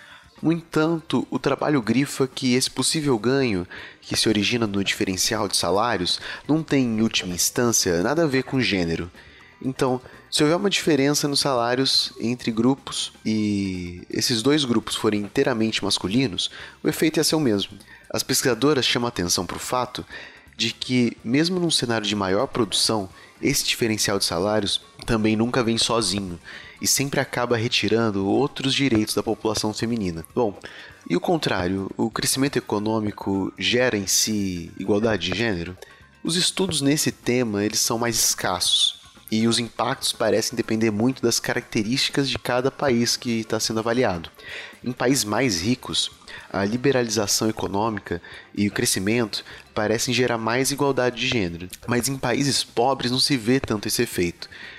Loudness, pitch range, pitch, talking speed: -22 LUFS, 105-130 Hz, 115 Hz, 160 wpm